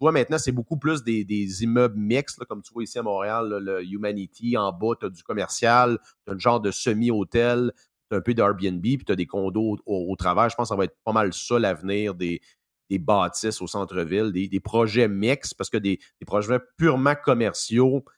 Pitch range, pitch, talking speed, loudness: 100-120 Hz, 110 Hz, 230 wpm, -24 LUFS